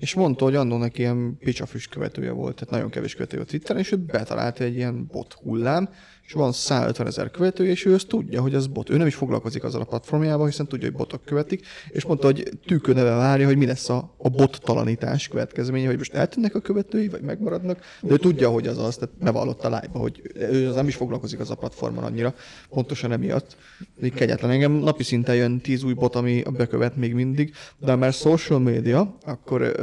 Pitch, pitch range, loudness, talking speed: 135 Hz, 125-155 Hz, -23 LUFS, 210 wpm